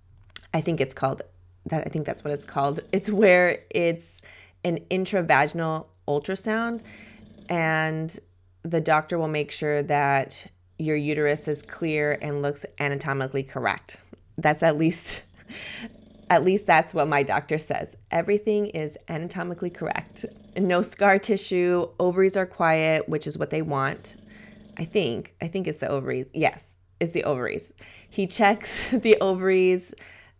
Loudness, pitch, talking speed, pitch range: -25 LUFS, 160 Hz, 140 wpm, 140-185 Hz